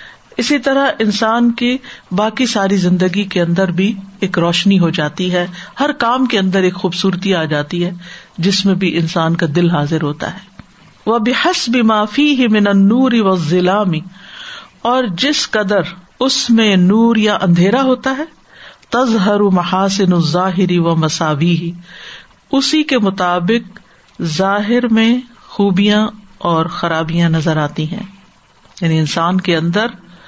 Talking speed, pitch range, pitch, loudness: 150 wpm, 175-230 Hz, 195 Hz, -14 LUFS